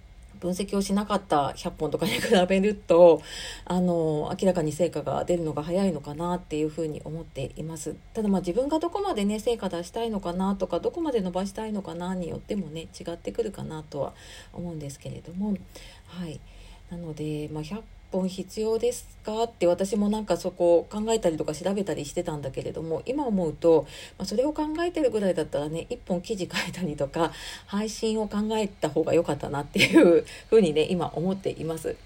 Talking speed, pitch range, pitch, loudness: 380 characters per minute, 160-210 Hz, 180 Hz, -27 LUFS